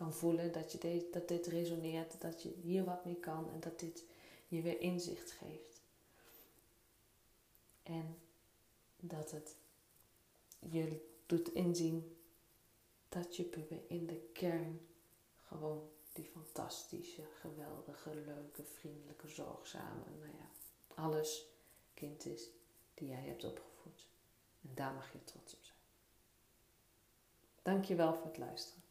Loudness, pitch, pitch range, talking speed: -44 LUFS, 160 Hz, 120-170 Hz, 125 wpm